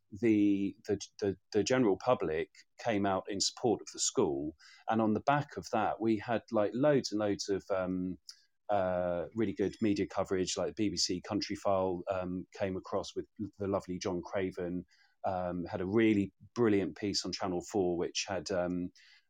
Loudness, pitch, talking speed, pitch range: -33 LUFS, 100 Hz, 175 wpm, 90-110 Hz